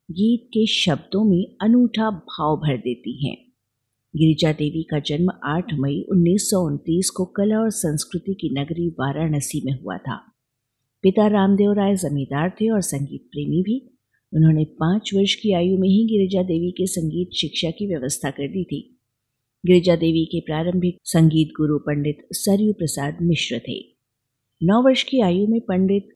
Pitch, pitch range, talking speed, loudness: 170 Hz, 145-195 Hz, 160 wpm, -21 LUFS